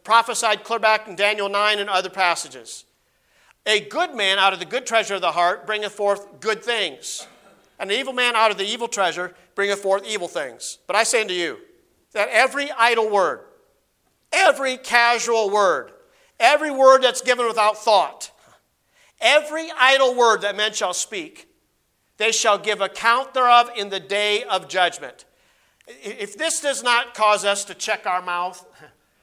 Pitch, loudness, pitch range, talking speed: 220 Hz, -19 LUFS, 200-265 Hz, 165 wpm